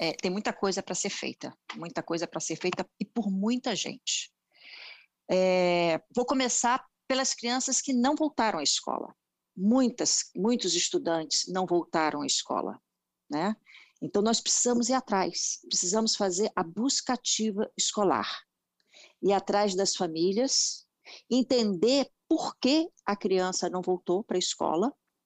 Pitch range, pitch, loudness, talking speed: 180-245 Hz, 205 Hz, -28 LUFS, 140 wpm